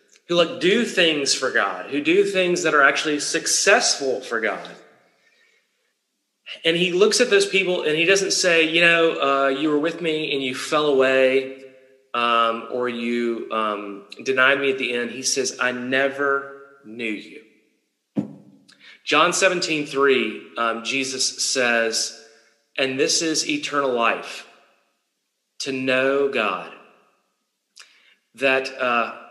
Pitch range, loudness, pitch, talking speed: 130-165 Hz, -20 LUFS, 140 Hz, 135 wpm